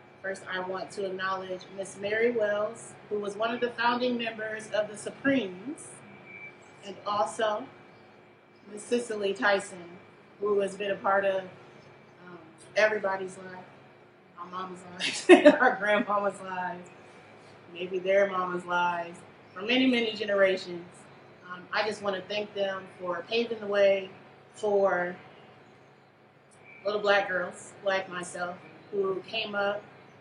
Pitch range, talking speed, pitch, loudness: 180-210 Hz, 130 wpm, 195 Hz, -28 LUFS